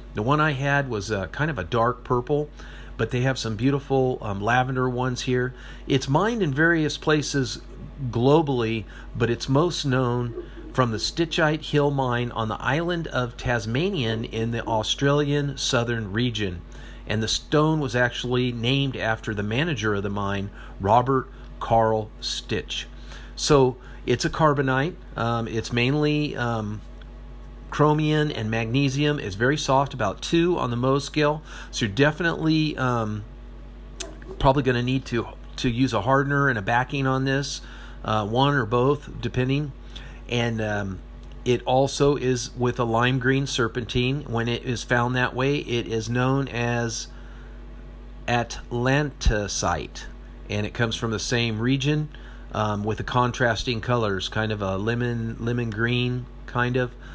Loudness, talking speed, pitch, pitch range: -24 LUFS, 150 wpm, 125 Hz, 115-140 Hz